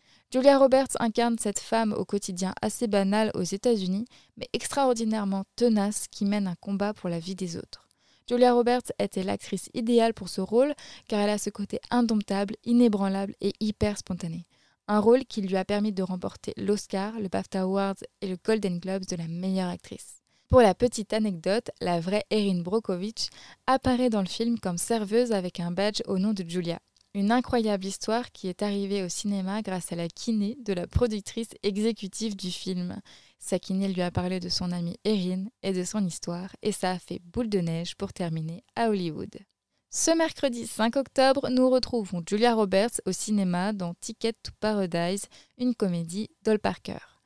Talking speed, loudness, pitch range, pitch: 180 wpm, -27 LUFS, 185-230 Hz, 205 Hz